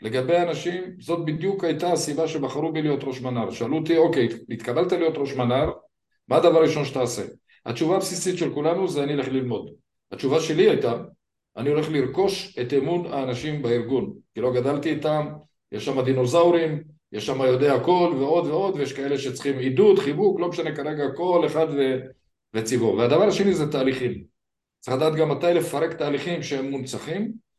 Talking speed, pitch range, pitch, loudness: 170 wpm, 130-170 Hz, 150 Hz, -23 LUFS